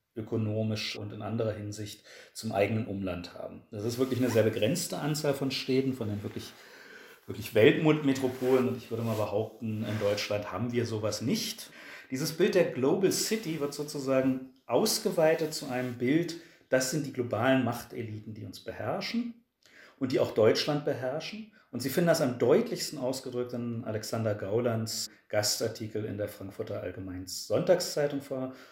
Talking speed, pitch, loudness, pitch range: 155 wpm, 125 Hz, -30 LUFS, 110-145 Hz